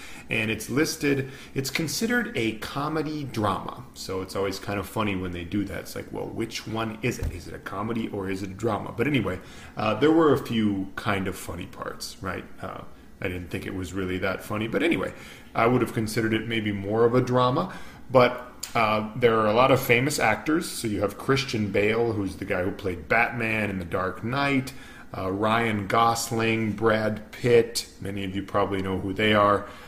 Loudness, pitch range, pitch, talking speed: -26 LUFS, 100-120 Hz, 110 Hz, 210 wpm